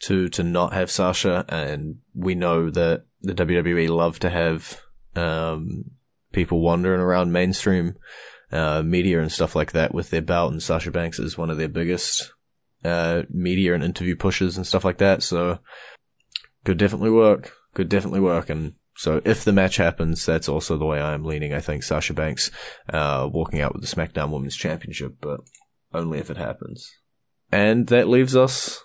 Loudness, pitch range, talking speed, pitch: -22 LUFS, 80-95 Hz, 180 wpm, 85 Hz